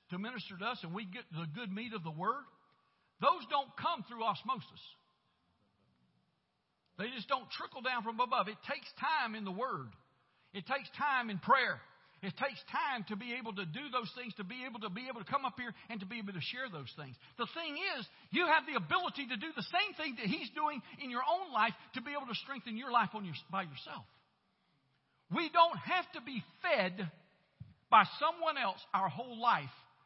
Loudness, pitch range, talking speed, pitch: -36 LUFS, 195-270 Hz, 210 wpm, 230 Hz